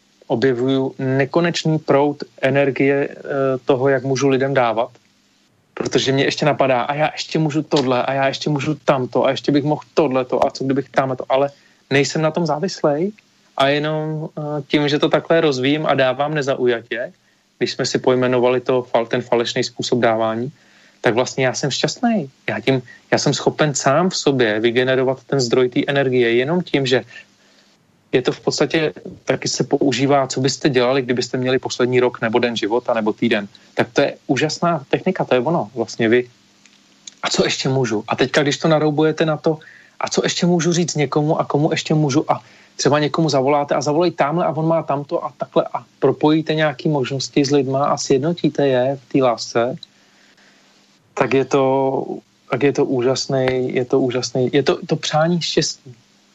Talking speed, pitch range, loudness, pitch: 180 wpm, 130-155 Hz, -18 LUFS, 140 Hz